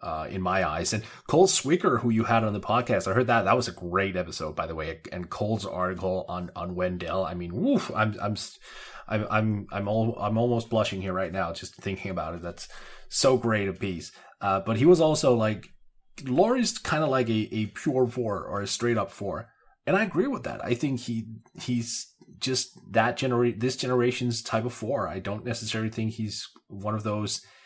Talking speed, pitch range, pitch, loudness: 215 wpm, 95-120 Hz, 110 Hz, -27 LUFS